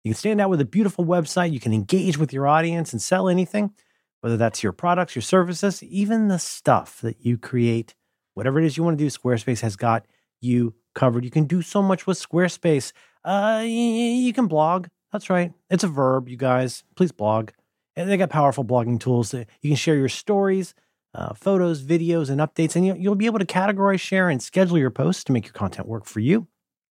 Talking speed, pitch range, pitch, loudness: 210 wpm, 125-190 Hz, 165 Hz, -22 LUFS